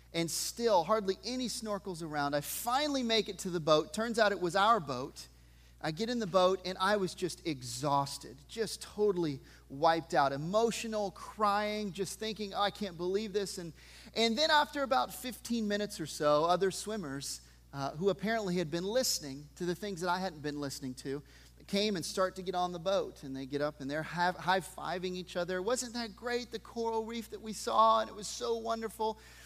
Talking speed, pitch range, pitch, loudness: 205 wpm, 160-220 Hz, 190 Hz, -33 LUFS